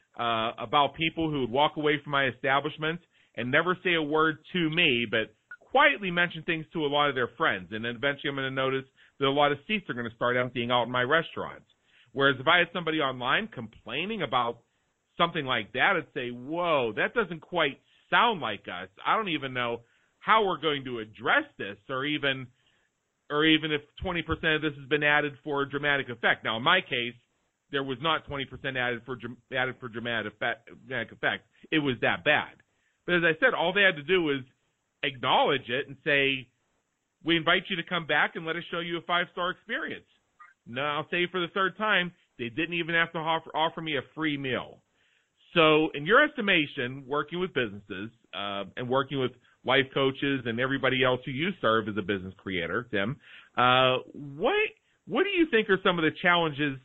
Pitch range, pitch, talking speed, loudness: 125-170 Hz, 145 Hz, 205 wpm, -27 LUFS